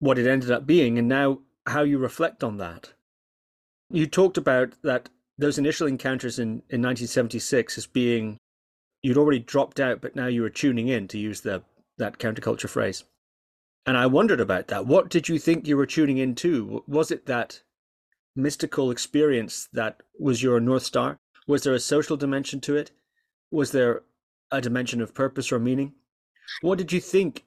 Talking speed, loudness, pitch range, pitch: 180 wpm, -24 LUFS, 120-150 Hz, 135 Hz